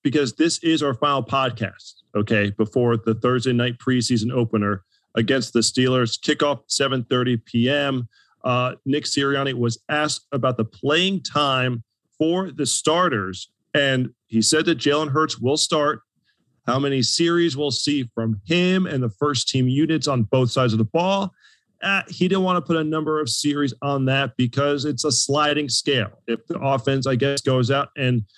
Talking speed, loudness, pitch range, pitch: 175 wpm, -21 LUFS, 120-150 Hz, 135 Hz